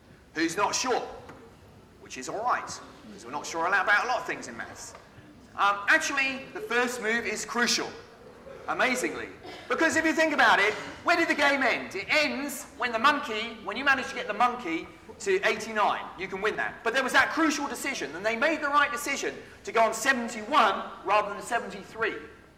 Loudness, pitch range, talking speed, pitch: -26 LUFS, 220-295 Hz, 195 wpm, 265 Hz